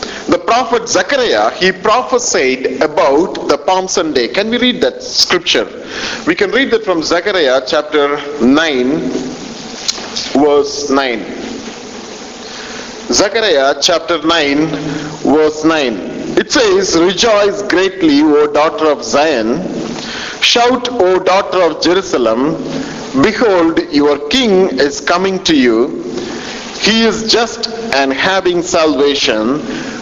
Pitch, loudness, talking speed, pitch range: 195 Hz, -12 LUFS, 110 wpm, 155-245 Hz